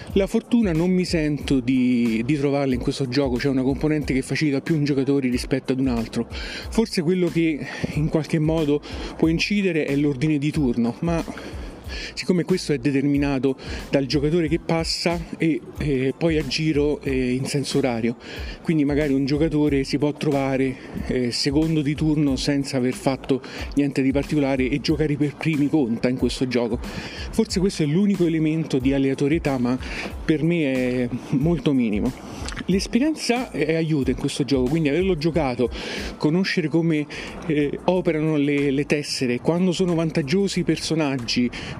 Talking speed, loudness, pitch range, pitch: 160 wpm, -22 LUFS, 135-165 Hz, 145 Hz